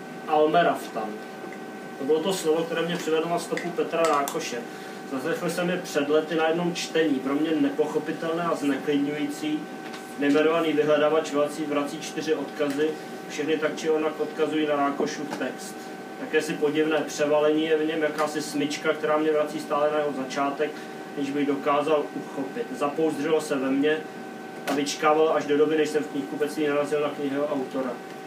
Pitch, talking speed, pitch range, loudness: 150 Hz, 160 wpm, 145-155 Hz, -26 LUFS